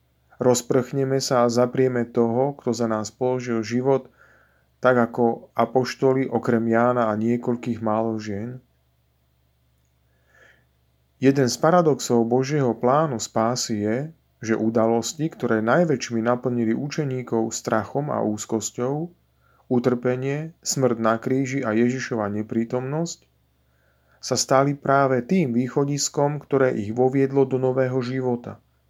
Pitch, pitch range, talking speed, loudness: 120 Hz, 110-130 Hz, 110 wpm, -22 LUFS